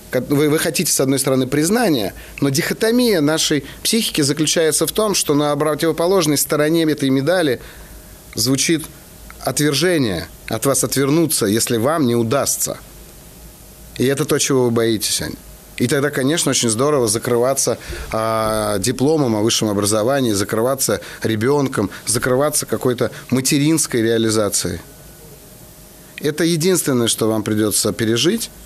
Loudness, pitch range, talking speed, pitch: -17 LUFS, 115-155 Hz, 120 wpm, 140 Hz